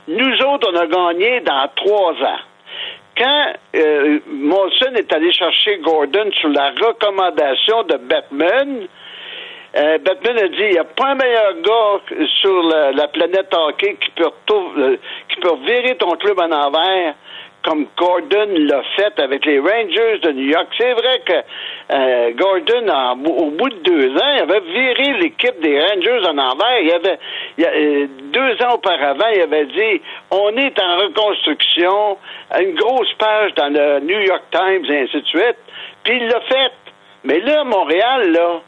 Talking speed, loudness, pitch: 170 wpm, -15 LUFS, 230 Hz